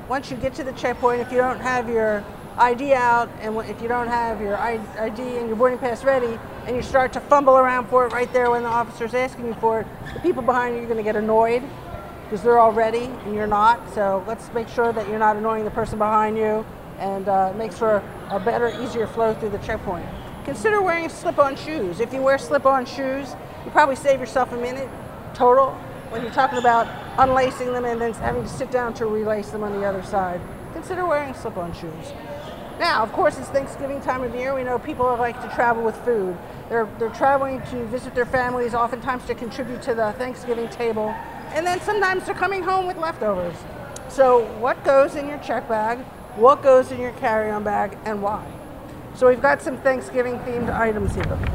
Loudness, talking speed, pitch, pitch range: -22 LUFS, 220 wpm, 240 Hz, 220-260 Hz